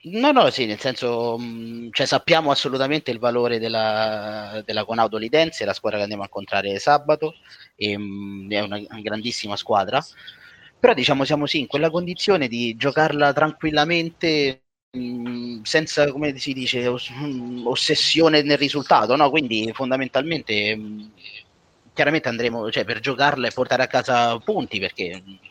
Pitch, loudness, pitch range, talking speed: 125 Hz, -21 LUFS, 110-145 Hz, 150 wpm